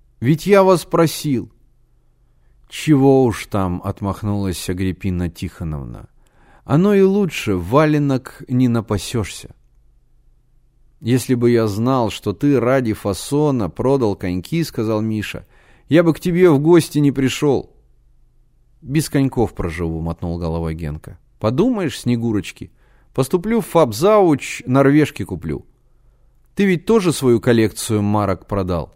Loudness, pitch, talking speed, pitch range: -18 LUFS, 125 Hz, 115 wpm, 100-145 Hz